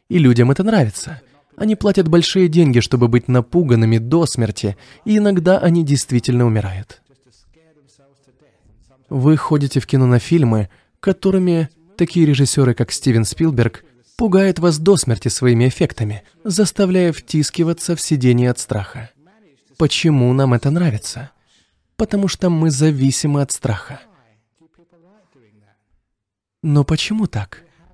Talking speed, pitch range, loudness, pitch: 120 wpm, 120-170 Hz, -16 LUFS, 145 Hz